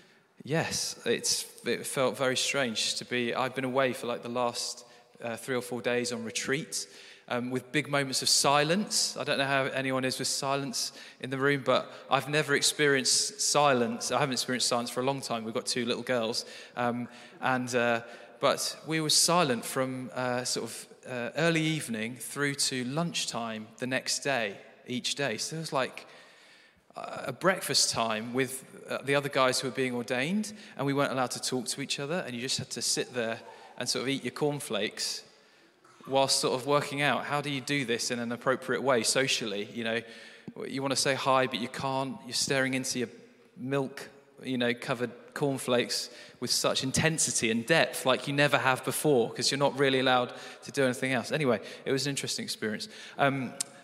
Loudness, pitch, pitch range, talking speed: -29 LUFS, 130 Hz, 125-140 Hz, 195 wpm